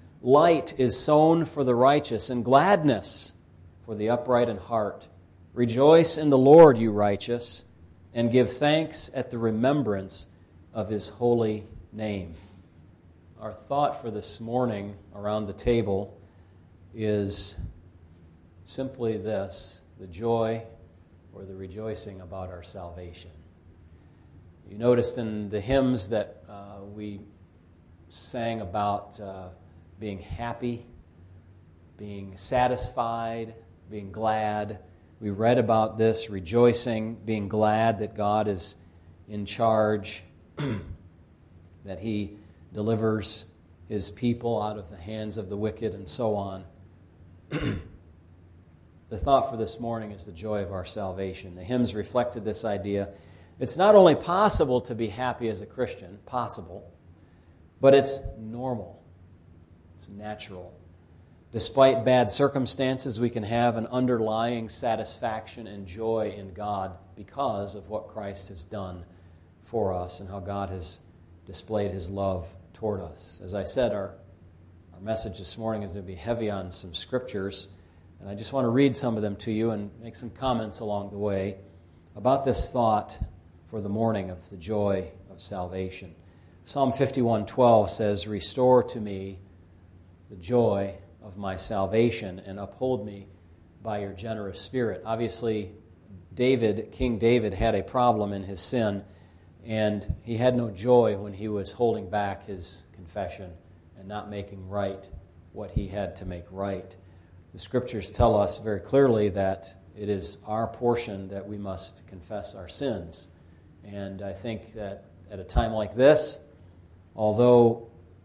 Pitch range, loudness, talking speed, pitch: 90-115 Hz, -26 LUFS, 140 wpm, 100 Hz